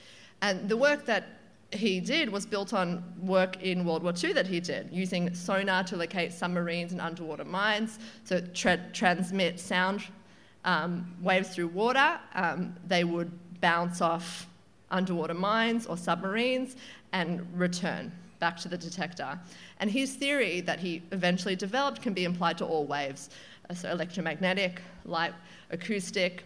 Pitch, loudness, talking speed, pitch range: 185 Hz, -30 LUFS, 145 wpm, 175-200 Hz